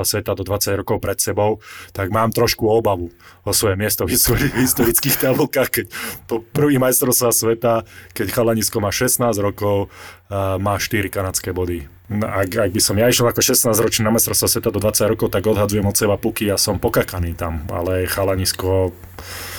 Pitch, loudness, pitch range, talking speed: 105 Hz, -18 LUFS, 95-115 Hz, 185 wpm